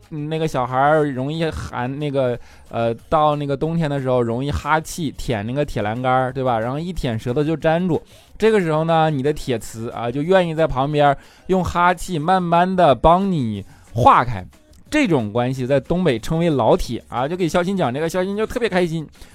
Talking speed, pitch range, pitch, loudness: 285 characters per minute, 125-170 Hz, 150 Hz, -19 LUFS